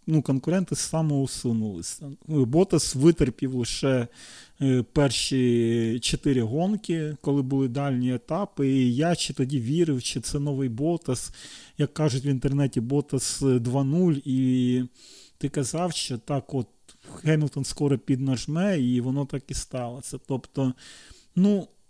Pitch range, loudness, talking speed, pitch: 125-155 Hz, -25 LUFS, 120 wpm, 140 Hz